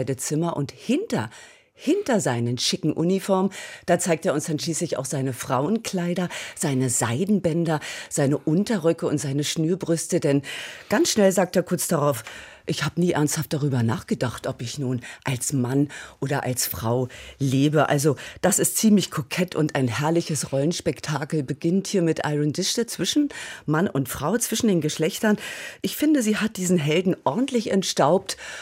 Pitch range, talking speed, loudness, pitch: 140-185 Hz, 155 wpm, -23 LUFS, 160 Hz